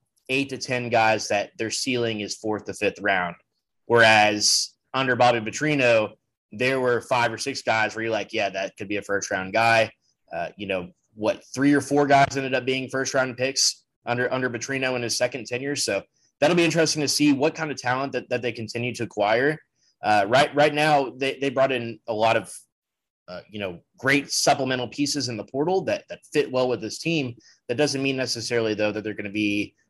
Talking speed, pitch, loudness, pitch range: 215 wpm, 125 Hz, -23 LUFS, 110-140 Hz